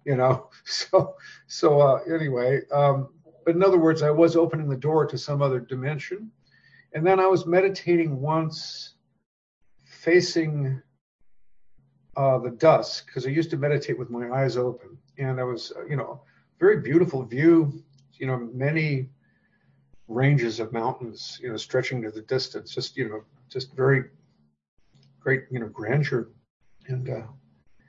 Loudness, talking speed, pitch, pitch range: -24 LUFS, 150 wpm, 135 Hz, 125-160 Hz